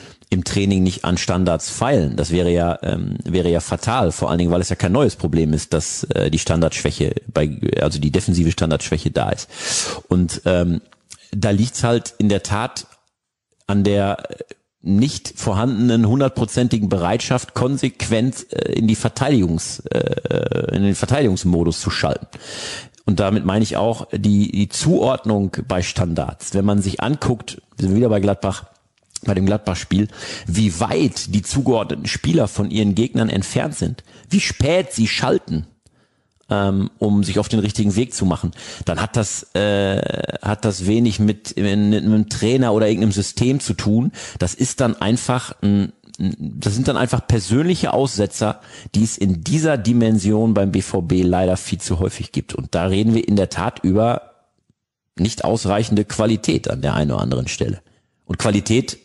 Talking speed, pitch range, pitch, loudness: 165 wpm, 95-115 Hz, 105 Hz, -19 LUFS